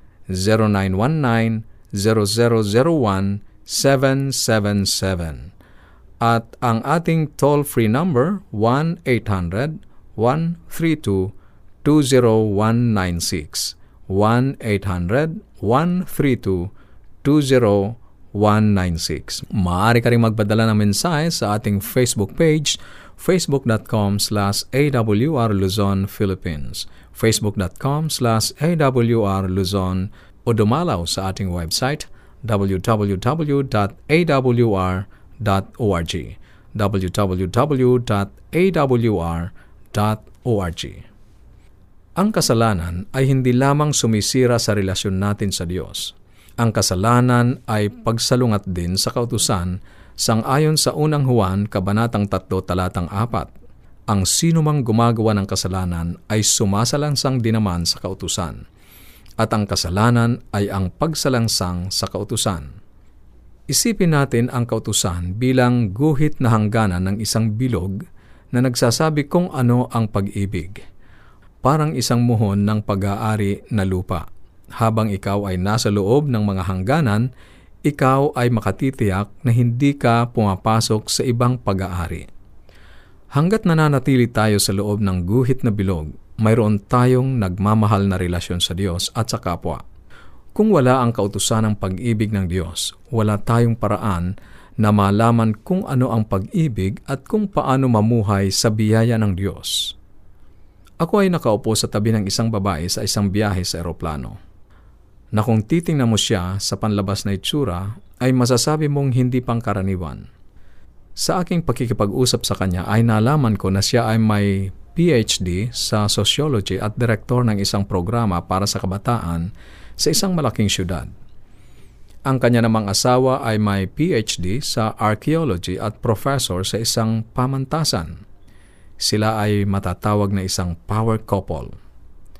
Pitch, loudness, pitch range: 110 Hz, -19 LUFS, 95-125 Hz